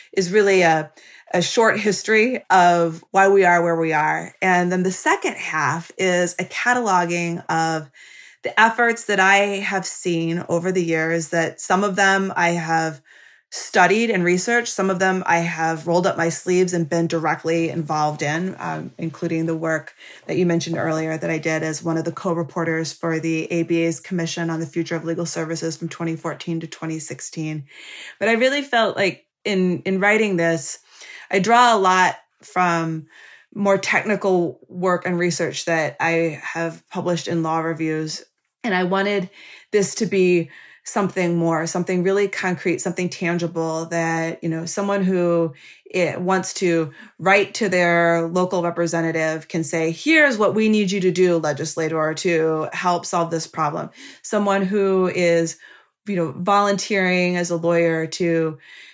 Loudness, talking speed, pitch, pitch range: -20 LUFS, 165 wpm, 175 Hz, 165-190 Hz